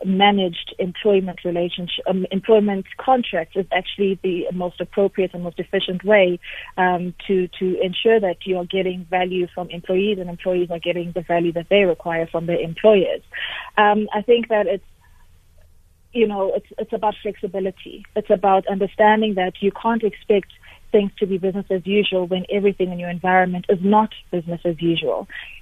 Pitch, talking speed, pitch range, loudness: 185 Hz, 165 wpm, 175-205 Hz, -20 LUFS